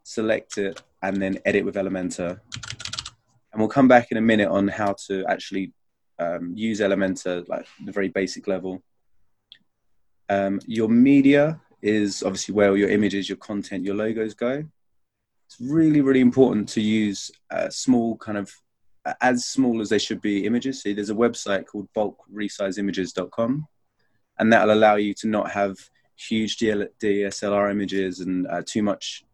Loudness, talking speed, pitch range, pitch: -23 LUFS, 165 wpm, 100-115 Hz, 105 Hz